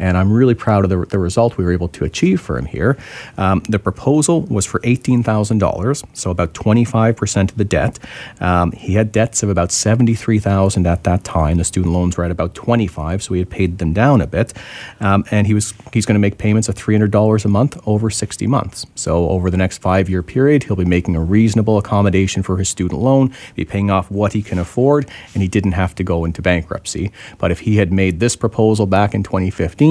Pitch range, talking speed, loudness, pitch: 90-110 Hz, 225 wpm, -16 LUFS, 100 Hz